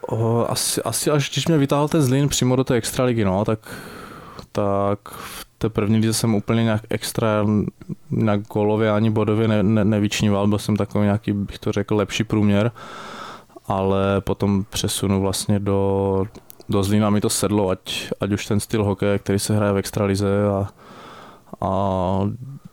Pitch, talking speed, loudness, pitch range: 105 Hz, 170 wpm, -21 LUFS, 100-115 Hz